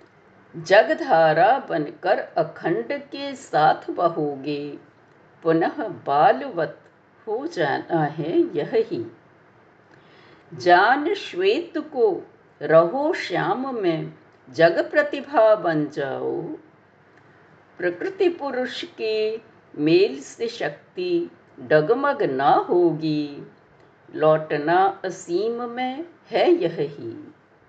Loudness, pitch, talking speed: -22 LUFS, 290 Hz, 80 wpm